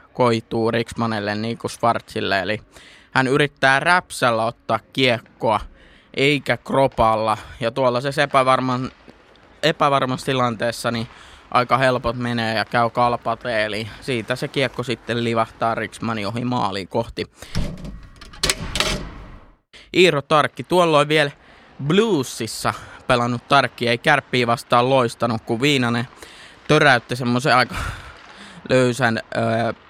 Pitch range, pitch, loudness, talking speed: 115-135 Hz, 120 Hz, -20 LUFS, 105 wpm